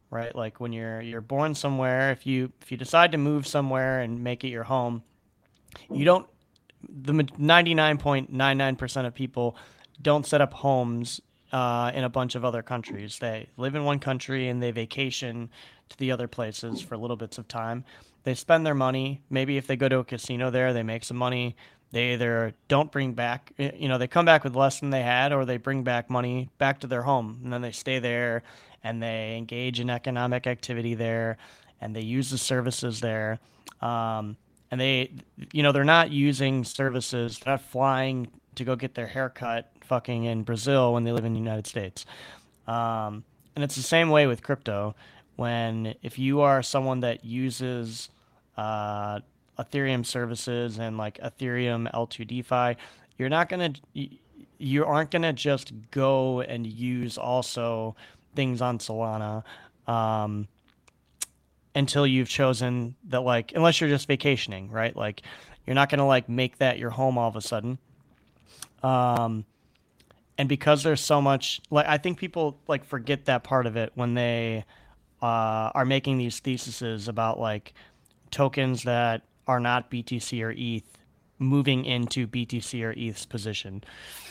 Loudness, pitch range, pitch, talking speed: -27 LUFS, 115-135 Hz, 125 Hz, 170 wpm